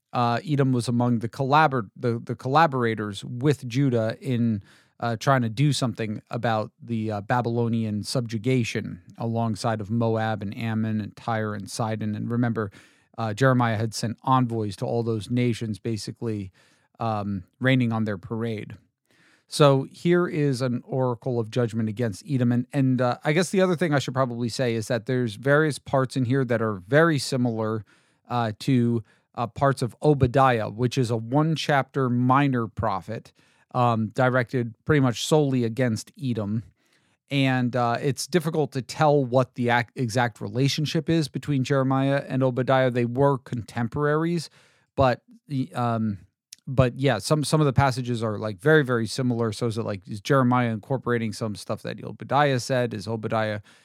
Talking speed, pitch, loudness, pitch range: 165 wpm, 120 Hz, -24 LUFS, 115-135 Hz